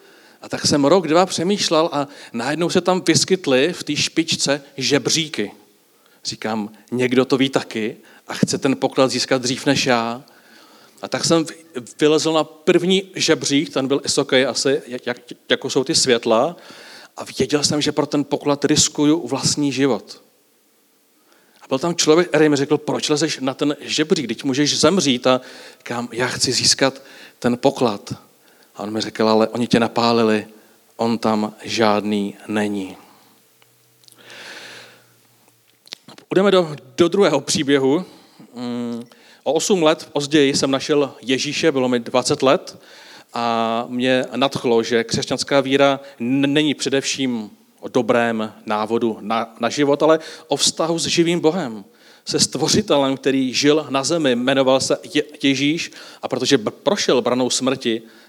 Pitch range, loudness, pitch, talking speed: 120-155 Hz, -18 LUFS, 135 Hz, 145 wpm